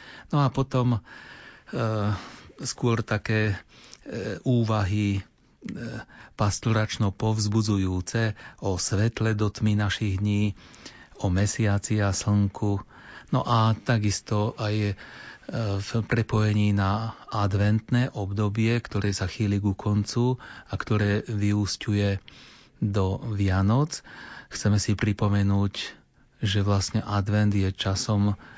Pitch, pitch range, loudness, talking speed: 105 Hz, 100-110 Hz, -26 LUFS, 100 wpm